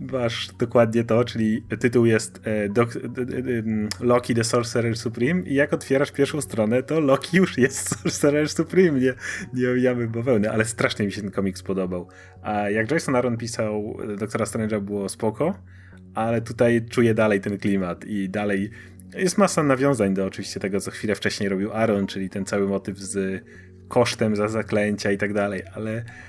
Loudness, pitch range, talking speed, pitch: -23 LUFS, 100-125 Hz, 175 wpm, 110 Hz